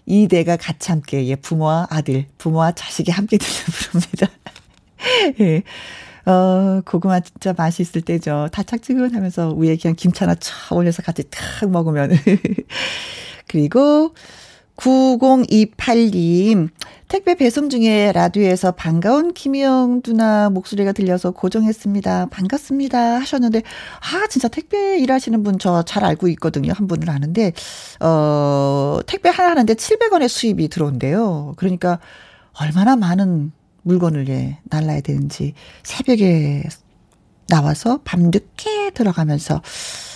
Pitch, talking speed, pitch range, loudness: 185 Hz, 270 characters per minute, 160-235 Hz, -17 LUFS